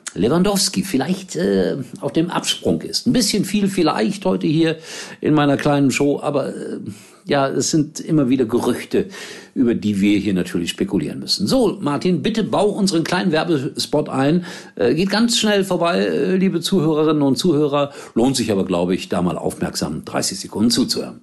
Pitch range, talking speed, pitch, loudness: 135-185 Hz, 170 wpm, 160 Hz, -18 LUFS